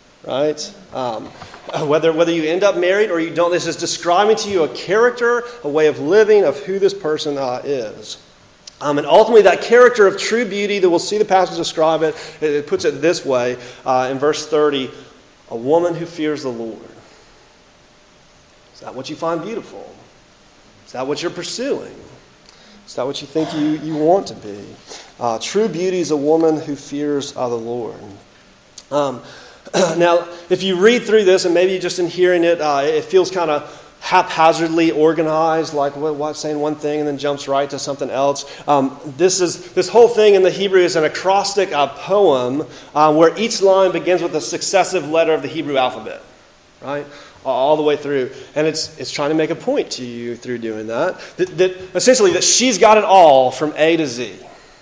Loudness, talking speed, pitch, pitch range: -16 LUFS, 195 wpm, 160 Hz, 145-185 Hz